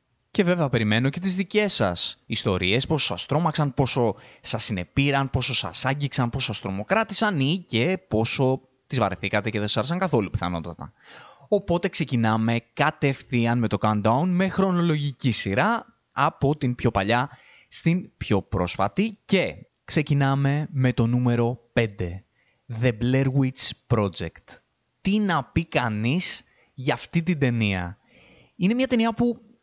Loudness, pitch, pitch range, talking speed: -24 LUFS, 130 Hz, 110-160 Hz, 140 wpm